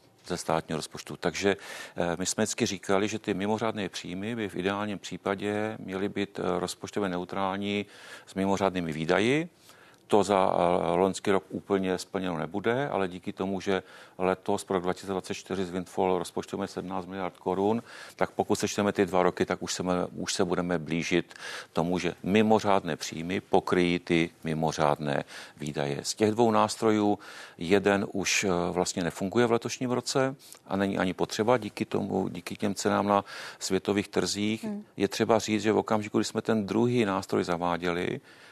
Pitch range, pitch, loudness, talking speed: 90-105 Hz, 95 Hz, -29 LUFS, 155 wpm